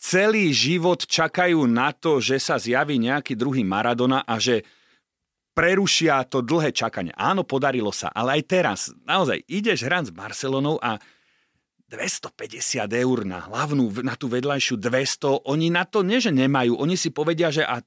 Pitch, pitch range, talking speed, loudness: 135 Hz, 125-165 Hz, 160 wpm, -22 LUFS